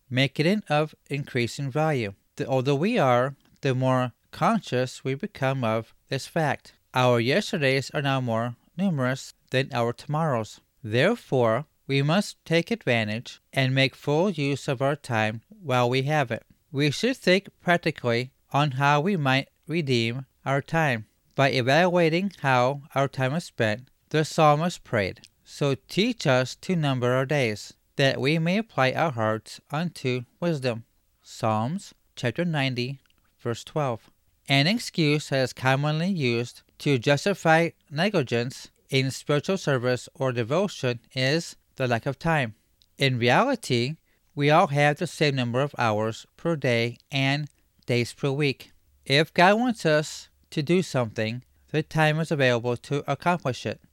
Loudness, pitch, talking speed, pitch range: -25 LUFS, 135 Hz, 145 wpm, 125-155 Hz